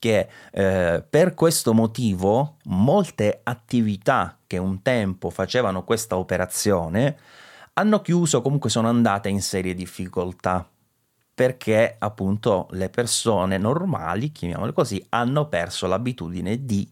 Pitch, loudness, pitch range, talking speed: 110 Hz, -22 LUFS, 95-125 Hz, 115 wpm